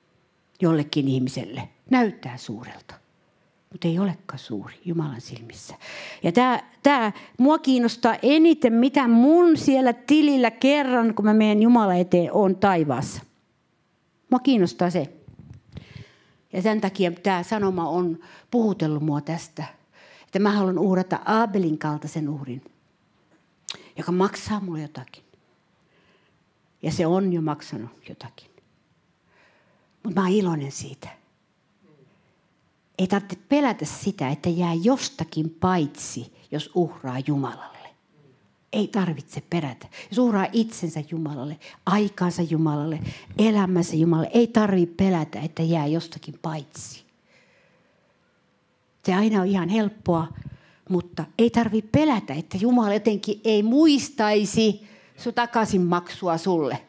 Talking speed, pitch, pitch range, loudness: 115 wpm, 180 Hz, 155-215 Hz, -23 LUFS